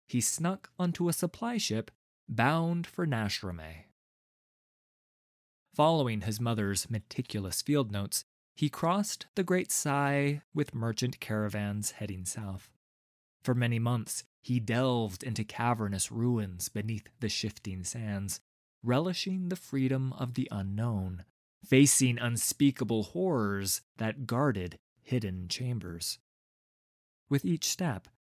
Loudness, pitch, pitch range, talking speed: -32 LUFS, 120 Hz, 105-145 Hz, 110 wpm